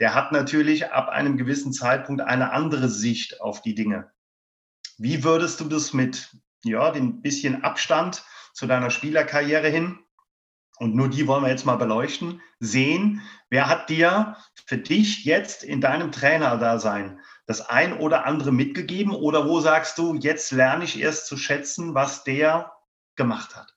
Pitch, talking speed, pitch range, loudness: 145 Hz, 160 wpm, 130-160 Hz, -23 LUFS